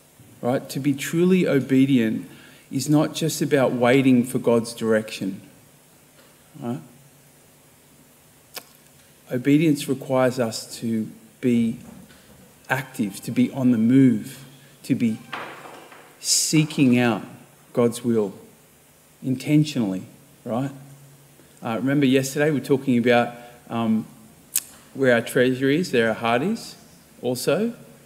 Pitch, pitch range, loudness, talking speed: 130 Hz, 120-140 Hz, -22 LUFS, 105 wpm